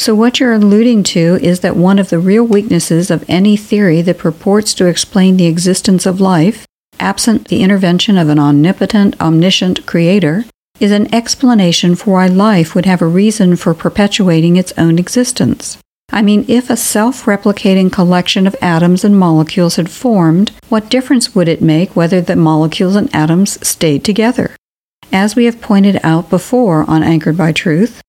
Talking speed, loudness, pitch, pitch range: 175 wpm, -10 LUFS, 190 Hz, 170-210 Hz